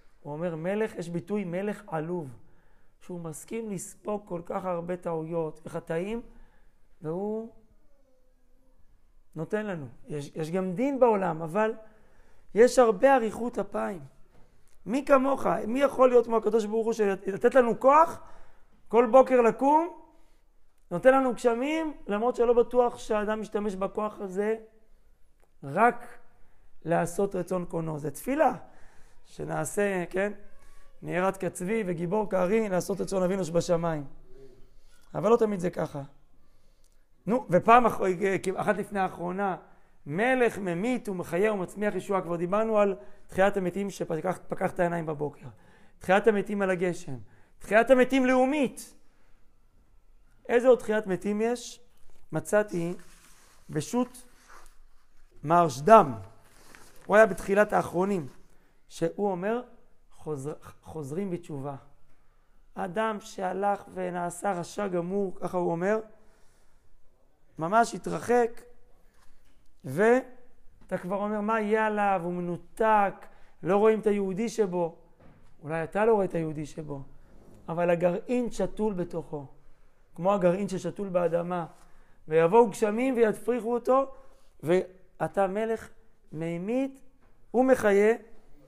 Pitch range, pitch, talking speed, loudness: 170-225 Hz, 195 Hz, 110 wpm, -27 LUFS